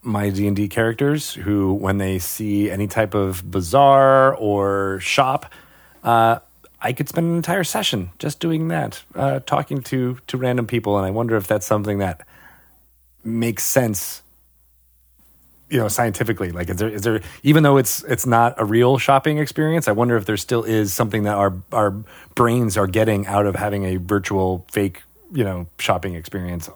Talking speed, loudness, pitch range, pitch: 180 wpm, -19 LUFS, 95-125 Hz, 105 Hz